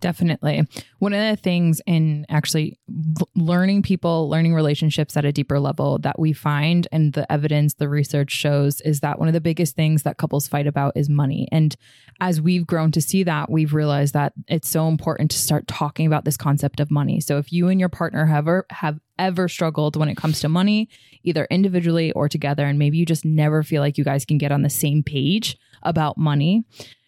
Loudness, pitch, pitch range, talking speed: -20 LUFS, 155 Hz, 145-170 Hz, 210 wpm